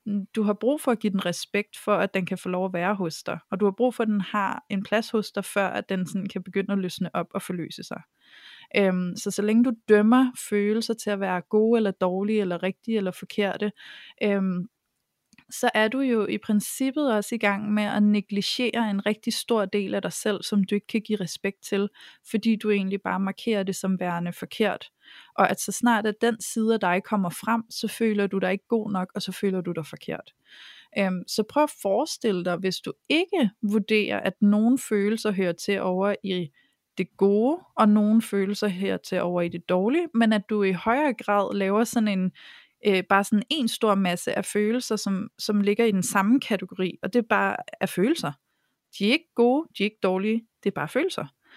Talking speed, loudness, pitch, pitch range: 220 wpm, -25 LUFS, 205 Hz, 195-225 Hz